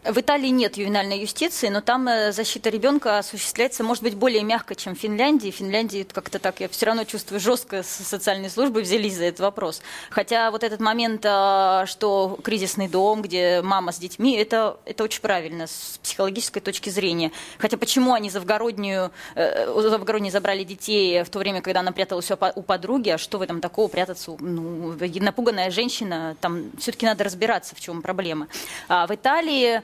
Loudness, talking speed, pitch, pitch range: -23 LUFS, 175 wpm, 205 Hz, 185-225 Hz